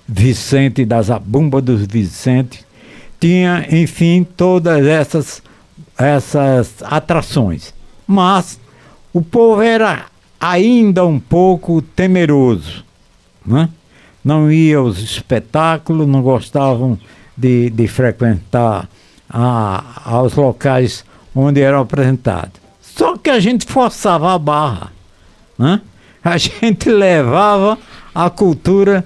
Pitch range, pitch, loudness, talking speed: 115-175 Hz, 140 Hz, -13 LUFS, 95 wpm